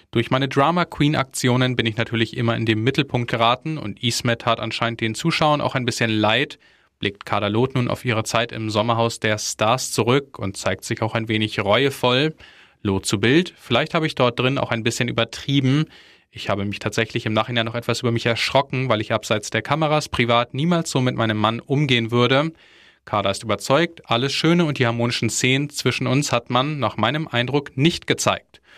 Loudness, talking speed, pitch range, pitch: -21 LUFS, 200 wpm, 115-140 Hz, 120 Hz